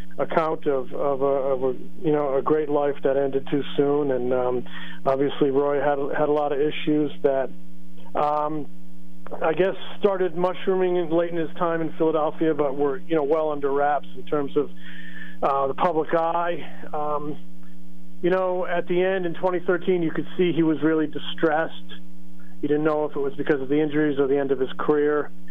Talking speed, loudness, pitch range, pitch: 195 wpm, -24 LUFS, 135-165 Hz, 150 Hz